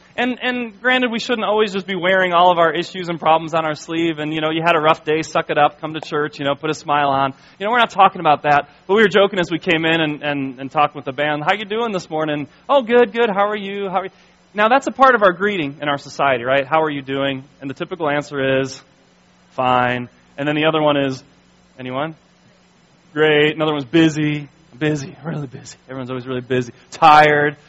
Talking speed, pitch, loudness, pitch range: 245 wpm, 155 Hz, -17 LUFS, 145-185 Hz